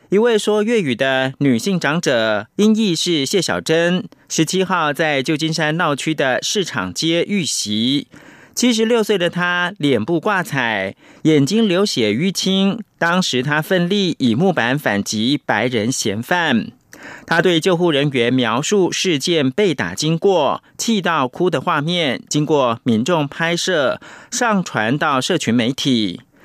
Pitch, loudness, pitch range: 170 Hz, -17 LUFS, 140-195 Hz